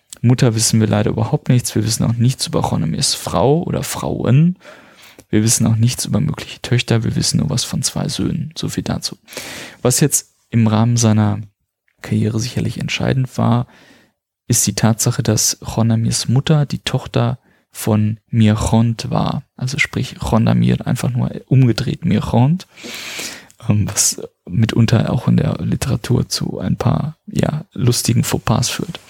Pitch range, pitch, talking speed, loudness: 110-130 Hz, 120 Hz, 150 wpm, -17 LUFS